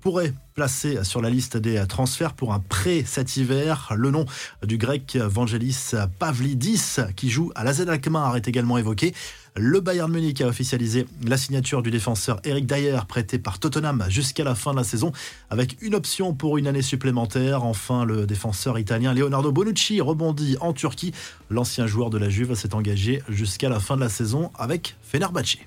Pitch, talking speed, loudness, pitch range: 130 Hz, 180 wpm, -24 LUFS, 115-150 Hz